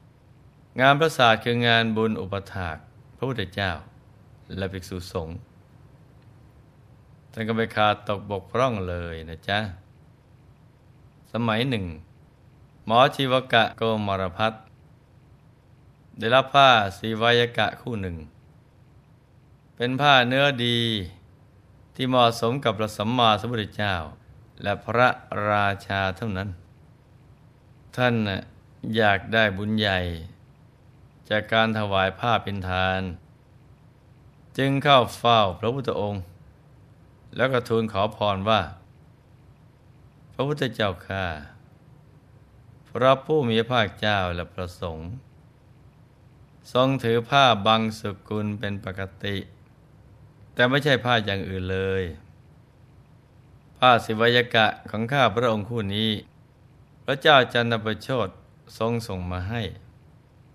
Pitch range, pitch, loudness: 100-130 Hz, 115 Hz, -23 LUFS